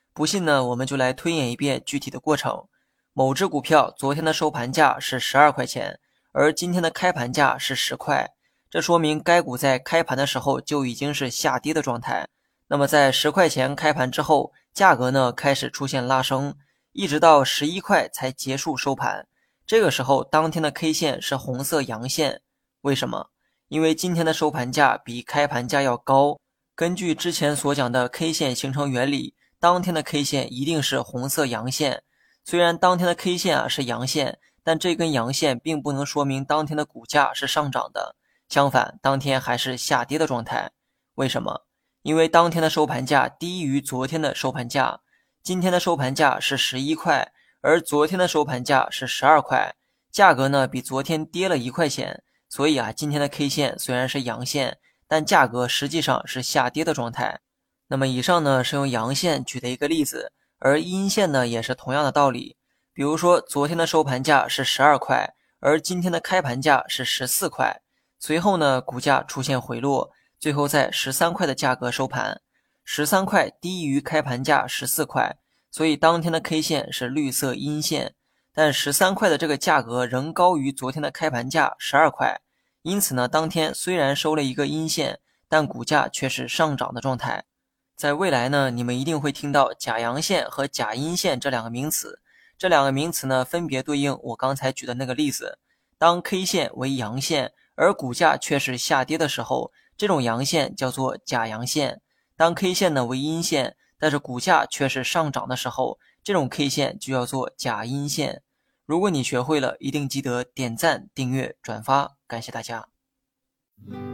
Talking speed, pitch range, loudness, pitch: 270 characters per minute, 130-160 Hz, -22 LUFS, 145 Hz